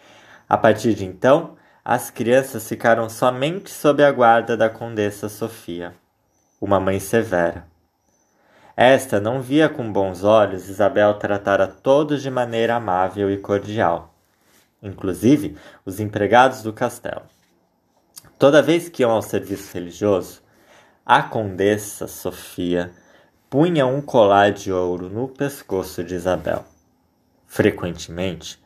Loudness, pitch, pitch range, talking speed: -19 LUFS, 105 Hz, 95-120 Hz, 120 wpm